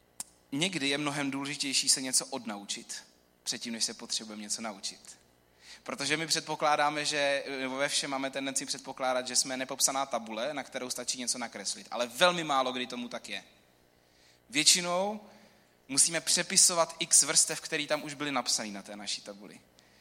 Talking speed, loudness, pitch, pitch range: 155 wpm, -29 LUFS, 135 Hz, 115-150 Hz